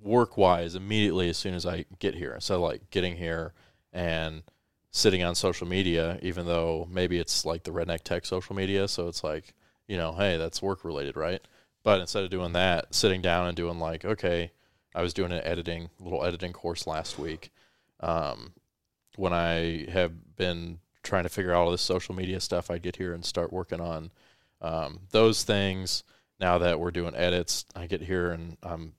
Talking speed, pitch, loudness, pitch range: 195 wpm, 90 Hz, -29 LUFS, 85-95 Hz